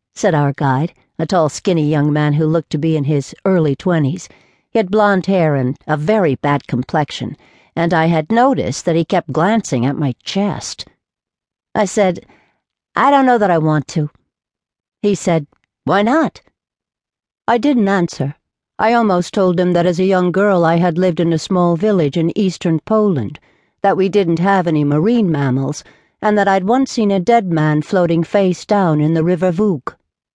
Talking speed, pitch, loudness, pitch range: 185 wpm, 175 Hz, -15 LUFS, 150-200 Hz